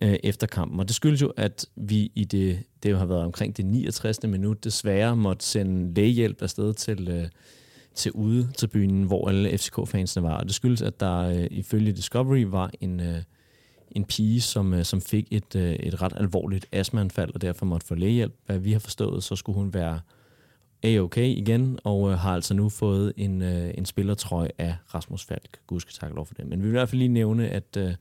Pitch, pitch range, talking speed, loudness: 100 Hz, 95-110 Hz, 195 wpm, -26 LUFS